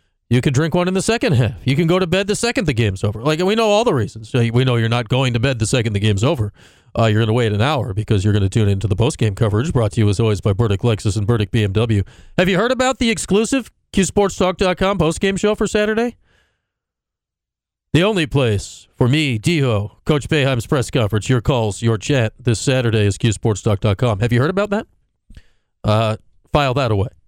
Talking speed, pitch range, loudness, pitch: 225 wpm, 110-160 Hz, -18 LUFS, 120 Hz